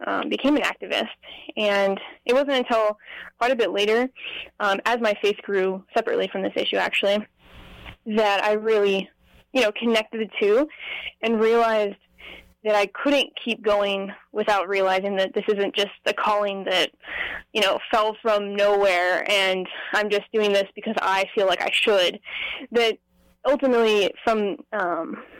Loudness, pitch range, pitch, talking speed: -22 LUFS, 200-230 Hz, 210 Hz, 155 wpm